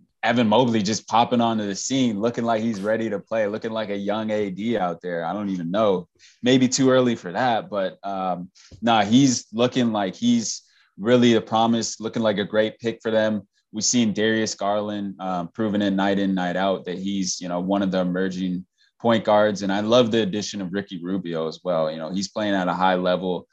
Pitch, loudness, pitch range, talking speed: 105 Hz, -22 LUFS, 95-115 Hz, 215 wpm